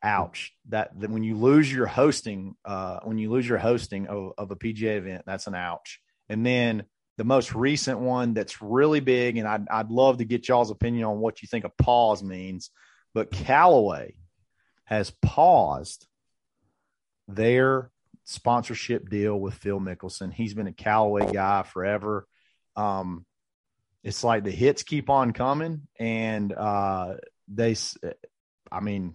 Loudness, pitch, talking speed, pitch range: -25 LUFS, 110 Hz, 155 wpm, 100-120 Hz